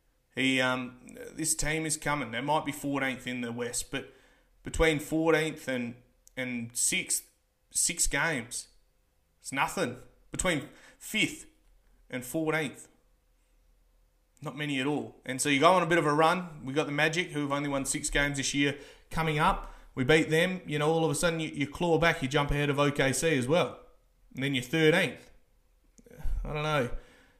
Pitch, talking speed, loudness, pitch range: 145 Hz, 180 wpm, -29 LUFS, 130-160 Hz